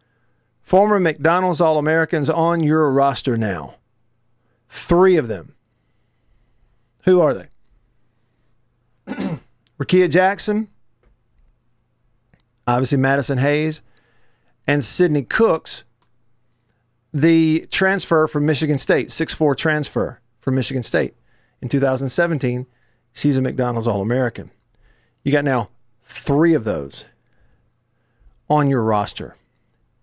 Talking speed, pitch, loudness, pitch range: 90 wpm, 125 Hz, -18 LUFS, 120-155 Hz